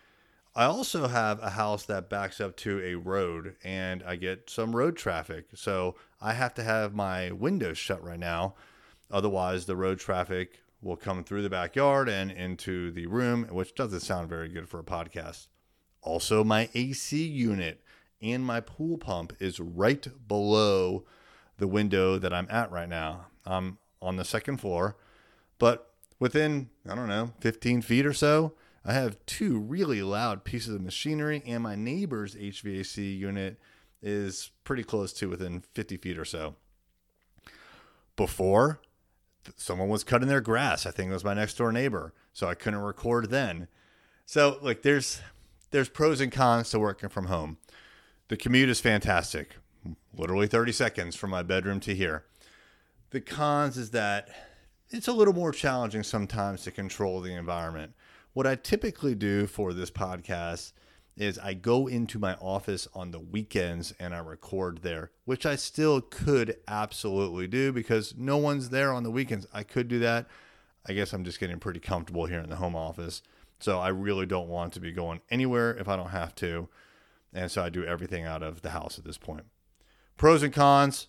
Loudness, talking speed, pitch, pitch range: -30 LUFS, 175 wpm, 100 Hz, 90-120 Hz